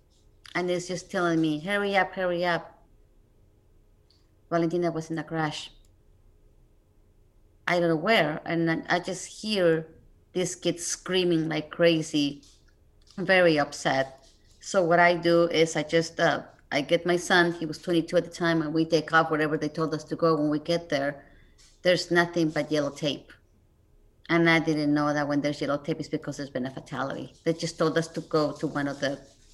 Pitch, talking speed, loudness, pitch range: 160 Hz, 185 wpm, -26 LUFS, 145-170 Hz